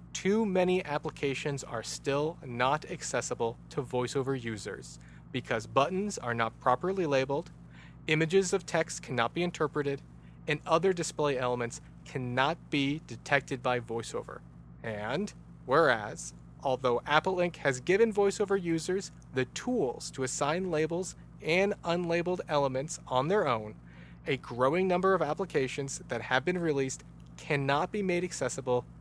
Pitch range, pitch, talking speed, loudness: 125-175 Hz, 140 Hz, 130 wpm, -31 LUFS